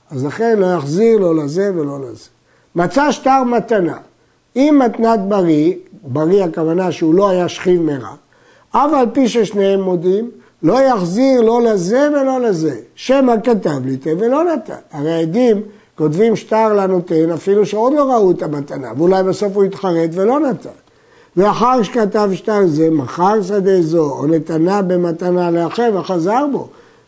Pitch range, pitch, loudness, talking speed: 170-230 Hz, 195 Hz, -15 LUFS, 145 wpm